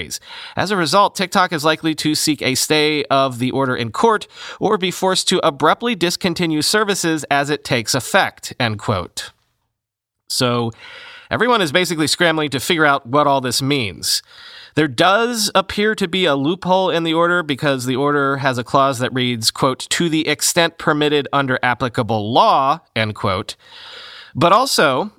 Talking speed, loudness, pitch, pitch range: 165 wpm, -17 LUFS, 150 Hz, 130-175 Hz